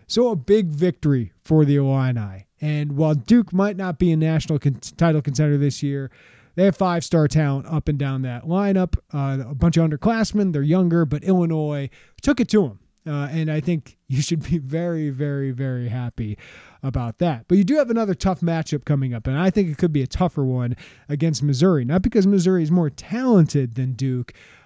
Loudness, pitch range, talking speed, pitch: -21 LUFS, 135-180 Hz, 205 wpm, 155 Hz